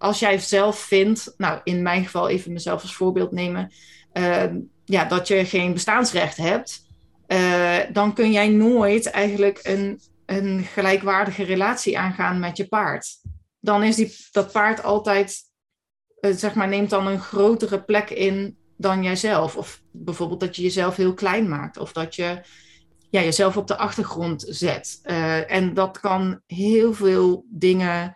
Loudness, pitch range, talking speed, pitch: -21 LUFS, 175-205 Hz, 160 wpm, 195 Hz